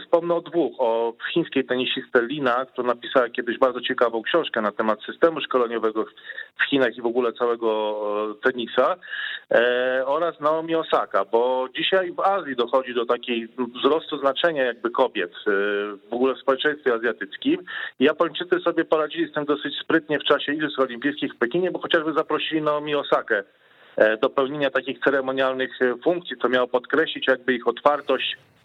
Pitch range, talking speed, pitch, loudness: 125-160 Hz, 150 wpm, 135 Hz, -23 LUFS